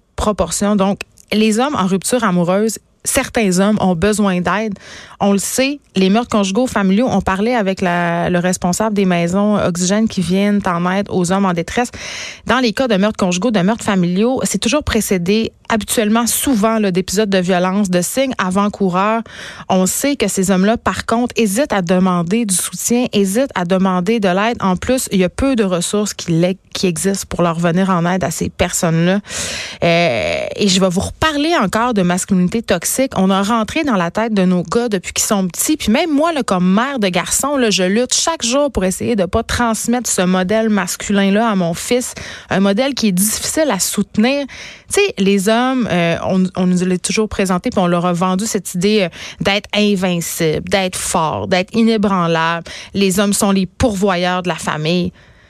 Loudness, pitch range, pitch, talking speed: -15 LUFS, 185-225 Hz, 200 Hz, 195 wpm